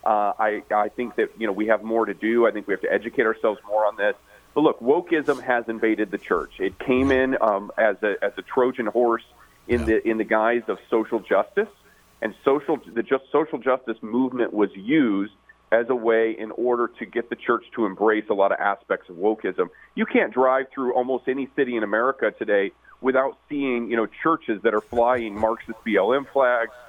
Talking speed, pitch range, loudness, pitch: 210 wpm, 110-130 Hz, -23 LUFS, 120 Hz